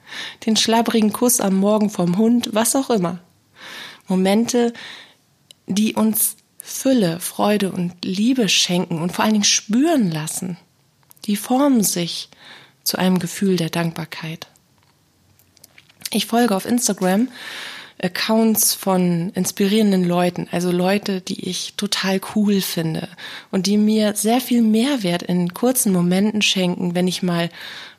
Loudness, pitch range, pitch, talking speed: -19 LUFS, 175-220 Hz, 195 Hz, 130 wpm